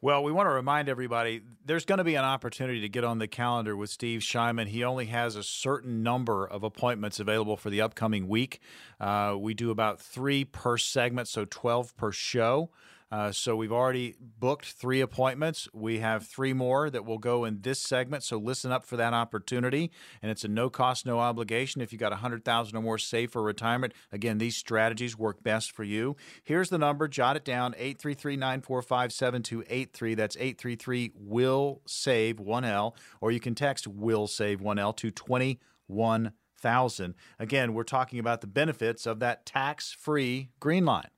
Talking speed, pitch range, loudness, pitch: 180 wpm, 110-130 Hz, -30 LUFS, 120 Hz